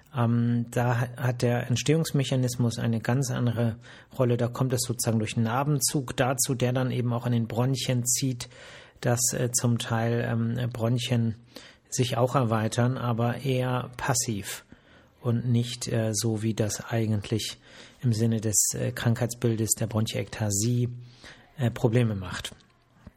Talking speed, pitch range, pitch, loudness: 125 wpm, 115-125 Hz, 120 Hz, -27 LUFS